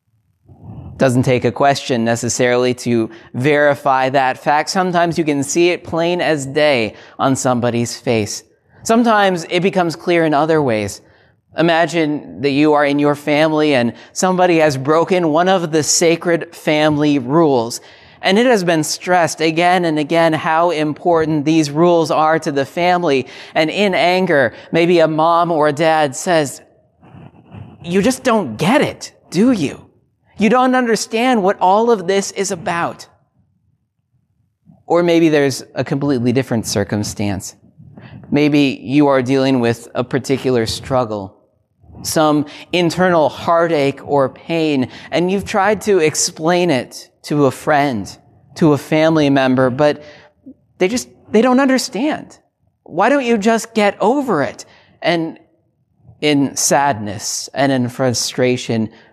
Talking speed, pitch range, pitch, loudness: 140 wpm, 125-170 Hz, 150 Hz, -15 LUFS